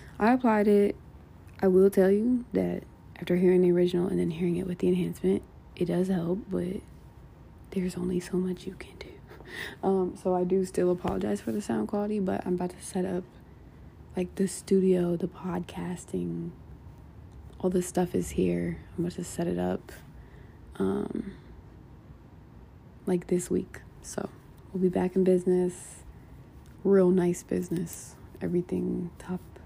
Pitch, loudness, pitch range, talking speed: 180 Hz, -28 LUFS, 175-185 Hz, 155 wpm